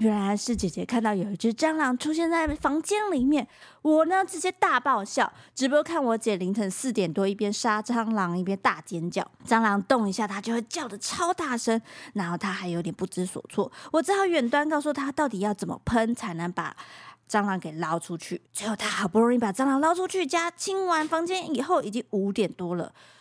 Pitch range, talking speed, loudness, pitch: 200-305 Hz, 305 characters per minute, -26 LUFS, 230 Hz